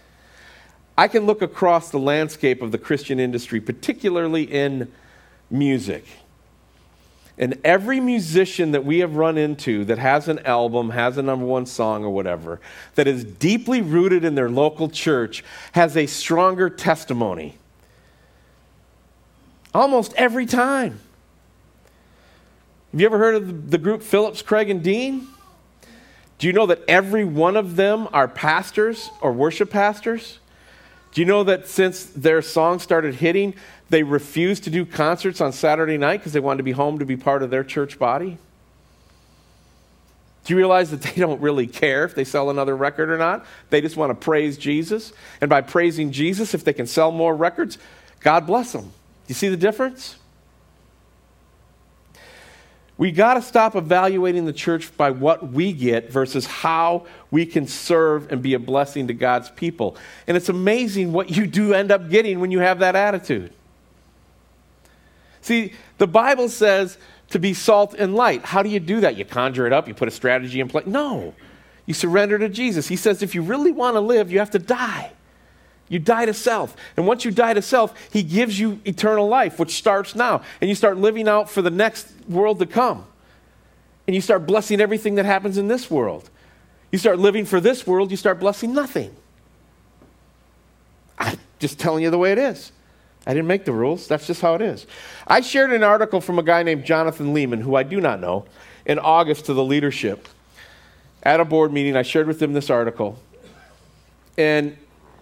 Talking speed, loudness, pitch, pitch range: 180 wpm, -20 LUFS, 170 Hz, 140-205 Hz